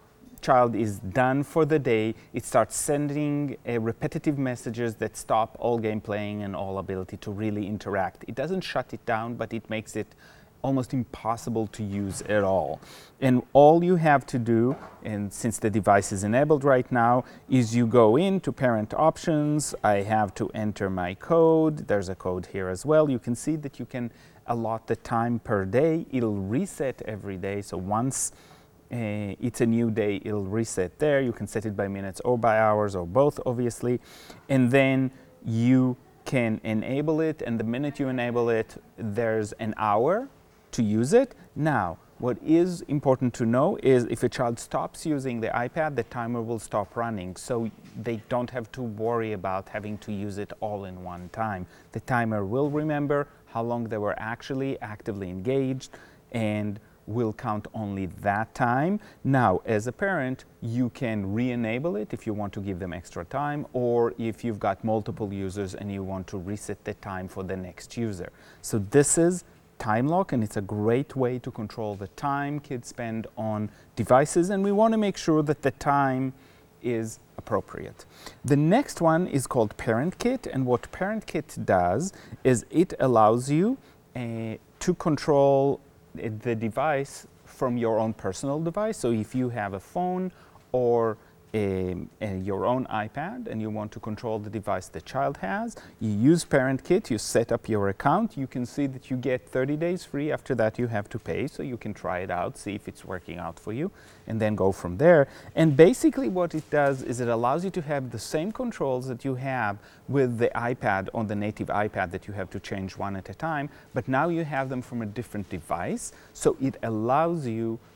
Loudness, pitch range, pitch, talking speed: -27 LUFS, 105-135 Hz, 115 Hz, 190 wpm